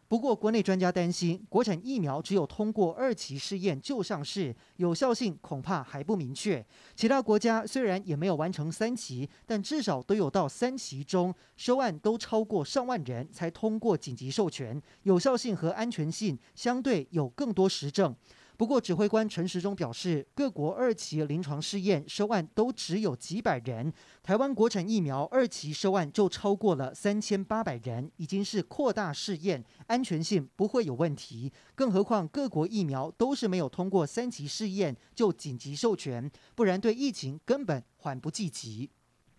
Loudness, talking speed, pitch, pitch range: -31 LUFS, 270 characters per minute, 190 Hz, 150-220 Hz